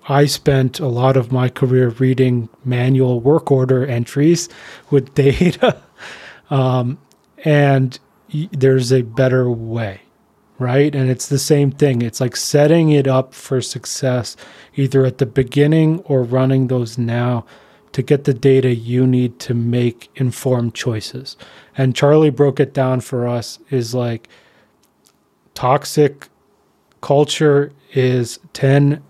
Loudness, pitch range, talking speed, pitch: -16 LUFS, 125-145 Hz, 135 wpm, 130 Hz